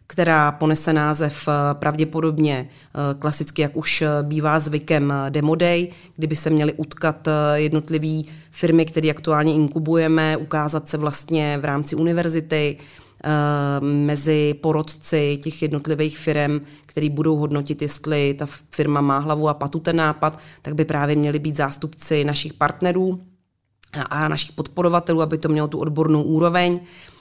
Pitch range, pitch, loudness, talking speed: 150-160 Hz, 155 Hz, -21 LUFS, 130 wpm